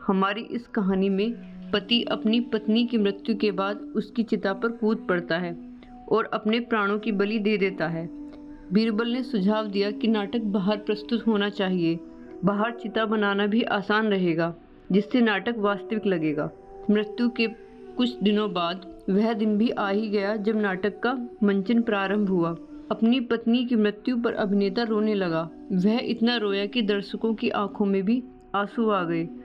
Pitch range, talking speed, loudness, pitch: 200-230 Hz, 165 wpm, -25 LUFS, 210 Hz